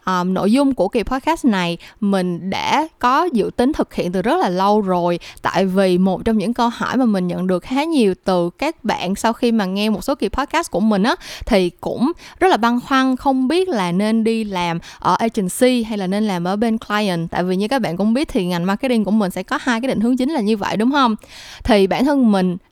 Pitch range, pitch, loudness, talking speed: 190-255 Hz, 220 Hz, -18 LUFS, 250 wpm